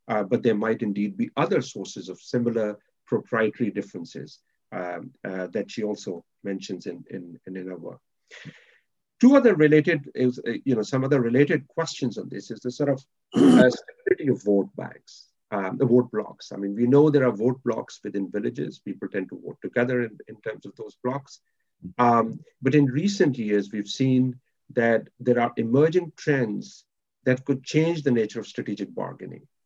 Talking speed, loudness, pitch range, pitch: 180 wpm, -24 LUFS, 105-140 Hz, 125 Hz